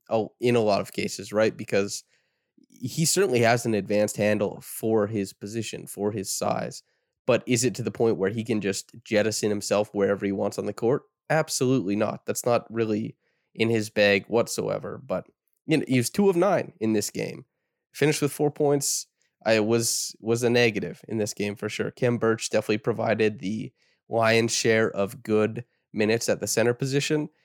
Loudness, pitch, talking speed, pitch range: -25 LUFS, 110 Hz, 190 wpm, 105-125 Hz